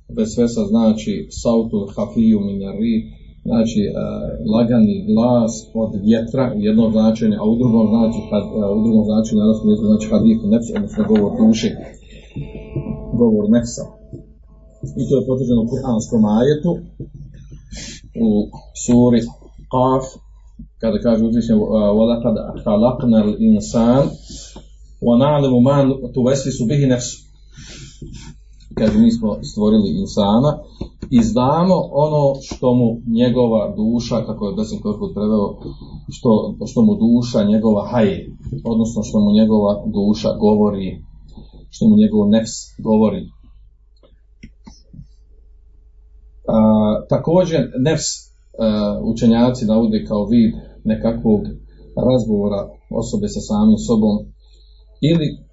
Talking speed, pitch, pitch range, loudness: 90 wpm, 115 Hz, 105-160 Hz, -16 LUFS